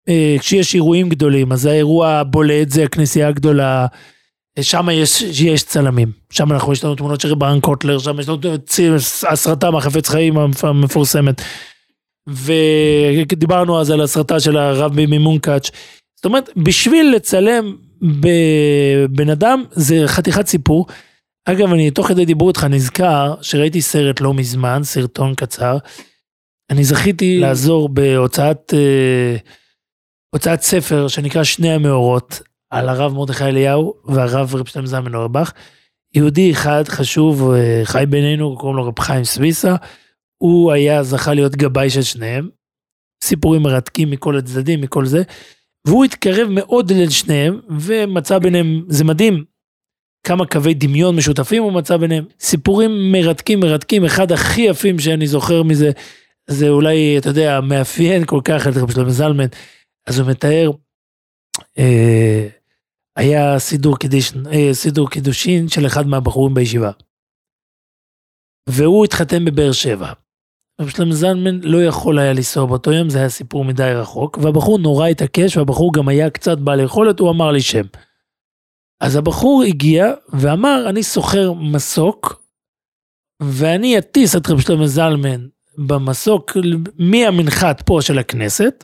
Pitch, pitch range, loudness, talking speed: 150 Hz, 140-170 Hz, -14 LUFS, 135 wpm